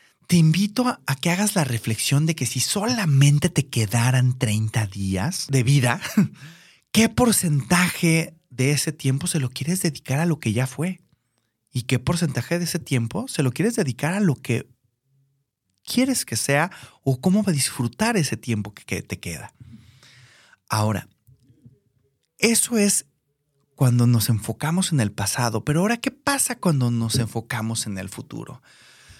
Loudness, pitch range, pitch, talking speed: -22 LUFS, 120-170 Hz, 135 Hz, 155 wpm